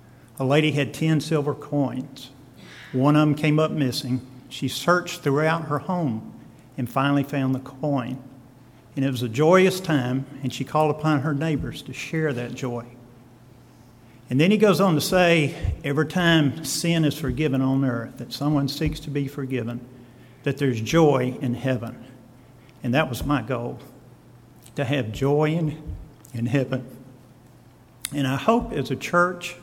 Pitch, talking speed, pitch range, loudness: 135 Hz, 160 wpm, 125-150 Hz, -23 LUFS